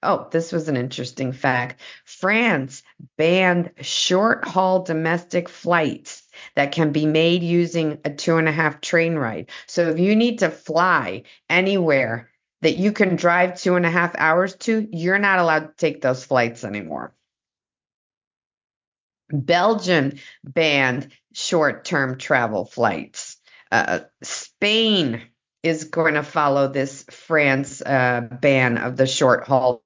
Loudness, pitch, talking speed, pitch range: -20 LUFS, 160 Hz, 140 wpm, 135-175 Hz